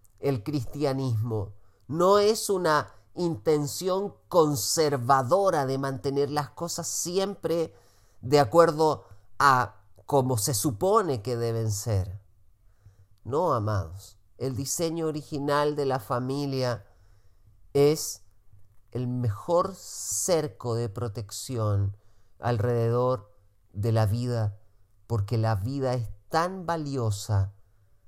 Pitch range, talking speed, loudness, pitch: 100-145 Hz, 95 wpm, -27 LUFS, 120 Hz